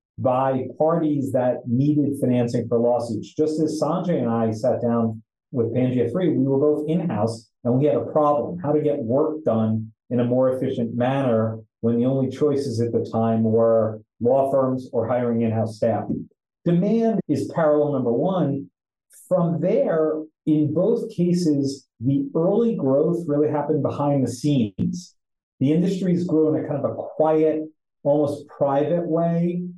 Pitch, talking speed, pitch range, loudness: 140 Hz, 165 wpm, 120-155 Hz, -22 LUFS